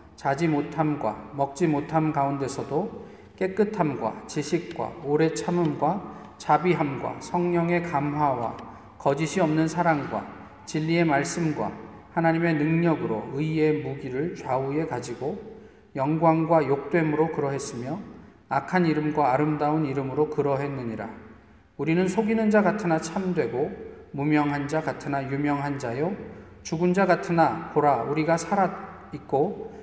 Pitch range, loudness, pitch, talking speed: 140-170 Hz, -25 LUFS, 155 Hz, 280 characters per minute